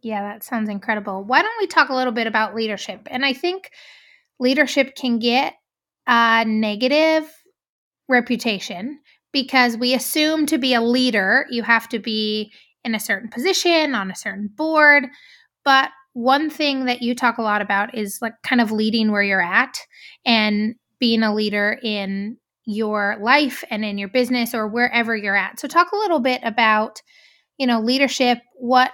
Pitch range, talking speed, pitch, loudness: 215-270 Hz, 170 wpm, 240 Hz, -19 LUFS